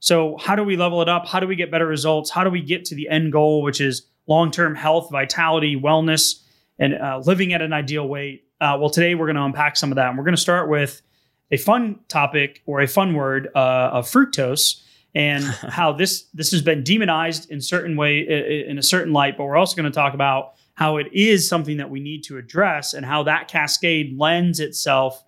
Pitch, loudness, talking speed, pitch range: 150 Hz, -19 LUFS, 230 wpm, 140-170 Hz